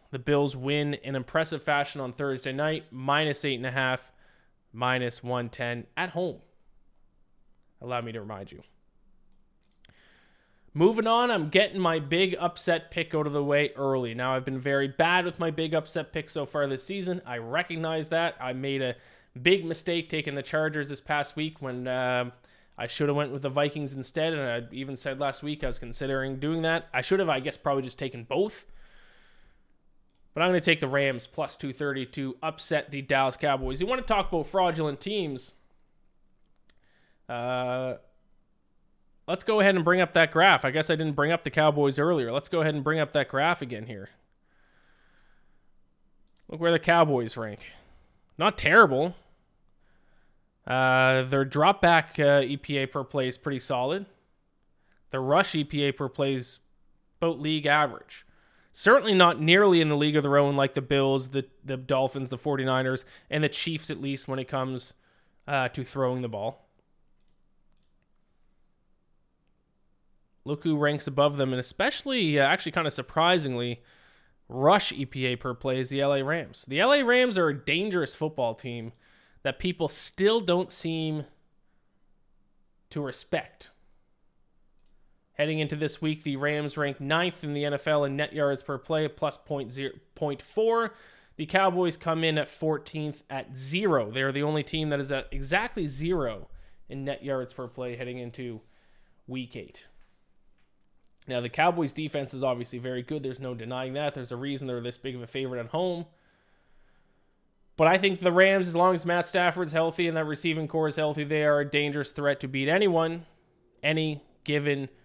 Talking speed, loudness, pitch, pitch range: 175 wpm, -27 LUFS, 145 Hz, 130-160 Hz